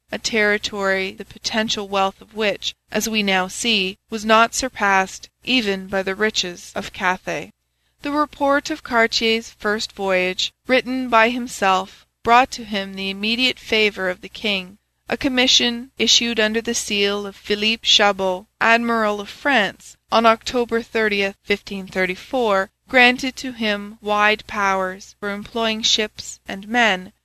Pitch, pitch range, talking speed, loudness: 215 Hz, 195-235 Hz, 145 wpm, -19 LUFS